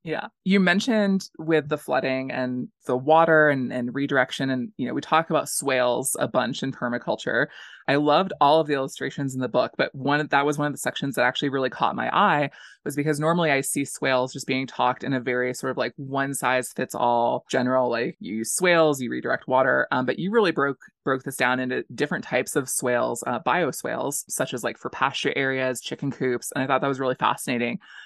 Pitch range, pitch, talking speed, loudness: 125-150 Hz, 135 Hz, 220 wpm, -24 LUFS